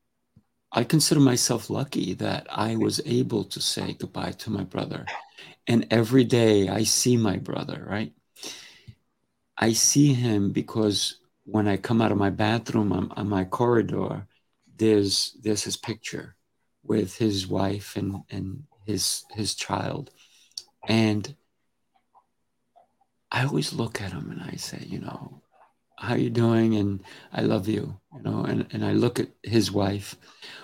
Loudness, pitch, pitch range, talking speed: -25 LUFS, 110 Hz, 100-115 Hz, 150 wpm